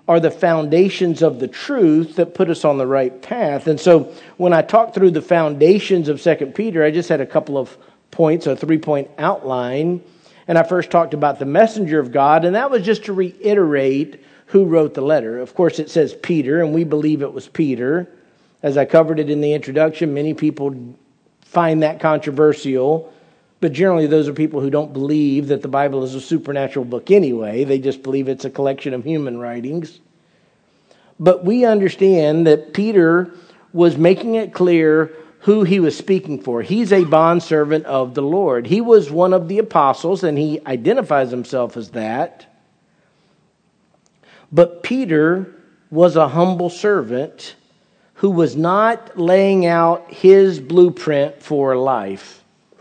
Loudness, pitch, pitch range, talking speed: -16 LUFS, 160 Hz, 145-180 Hz, 170 wpm